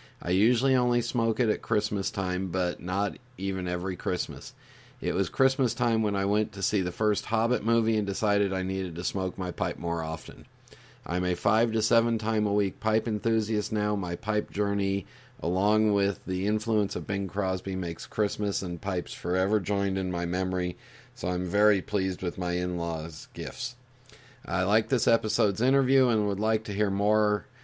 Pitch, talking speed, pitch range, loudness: 100 Hz, 185 wpm, 95-110 Hz, -28 LUFS